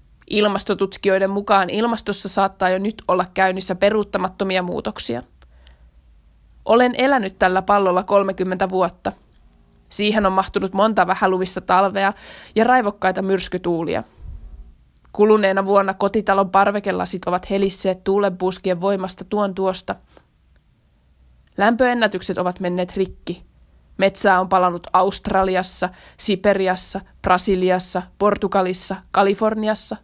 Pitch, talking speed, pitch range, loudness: 190 Hz, 95 wpm, 180-200 Hz, -19 LUFS